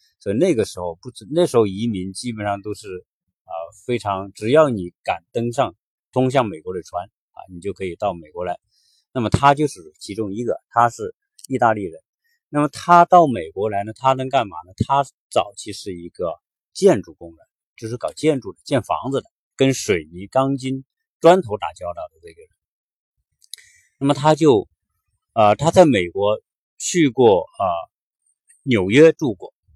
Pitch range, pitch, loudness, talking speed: 100-165 Hz, 130 Hz, -19 LUFS, 245 characters per minute